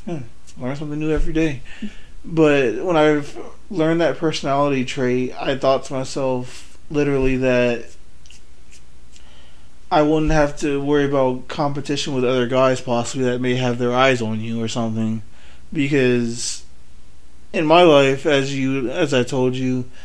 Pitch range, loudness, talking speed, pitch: 120-145 Hz, -19 LUFS, 145 wpm, 130 Hz